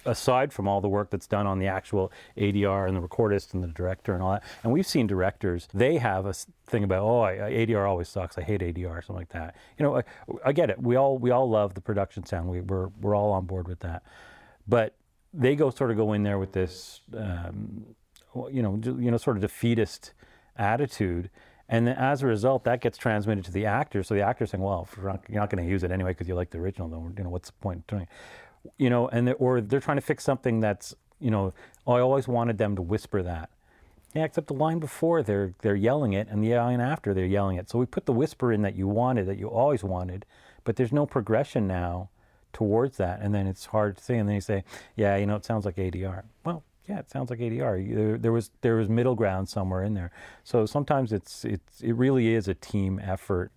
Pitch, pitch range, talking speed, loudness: 105 Hz, 95-120 Hz, 245 wpm, -27 LUFS